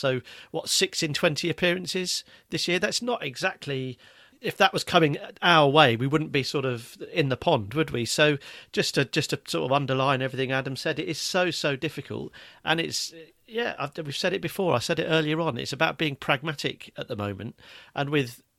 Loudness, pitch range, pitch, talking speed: -26 LUFS, 135-165 Hz, 155 Hz, 215 wpm